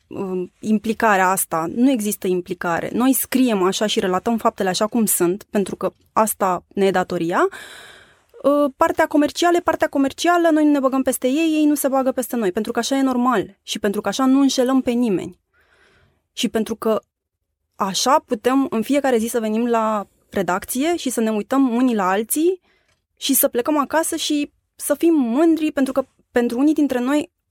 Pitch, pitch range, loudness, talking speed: 245 Hz, 205-280 Hz, -19 LUFS, 180 wpm